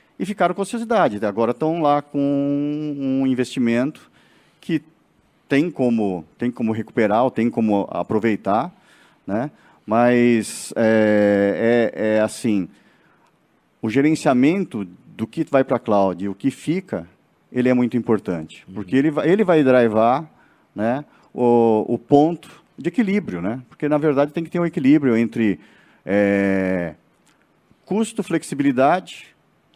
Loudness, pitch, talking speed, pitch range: -20 LUFS, 125 Hz, 135 wpm, 110-150 Hz